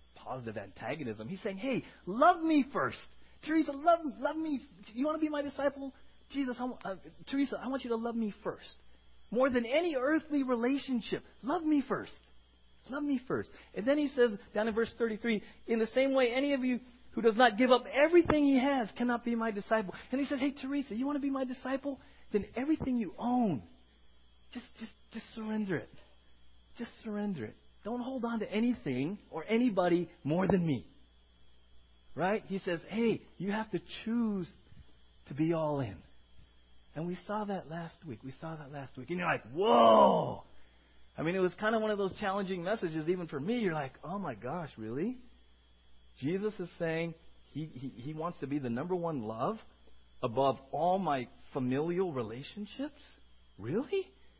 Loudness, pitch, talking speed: -33 LUFS, 200 Hz, 185 wpm